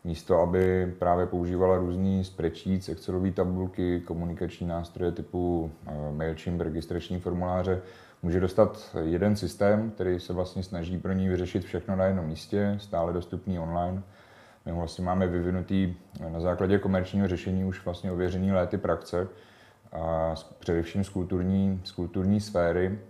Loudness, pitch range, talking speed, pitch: -29 LUFS, 85-95 Hz, 130 wpm, 90 Hz